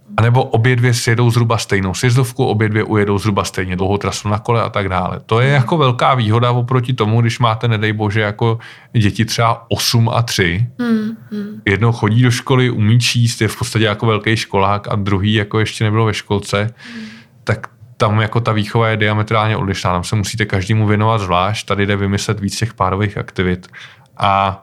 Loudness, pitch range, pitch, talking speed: -15 LUFS, 100-120 Hz, 110 Hz, 190 wpm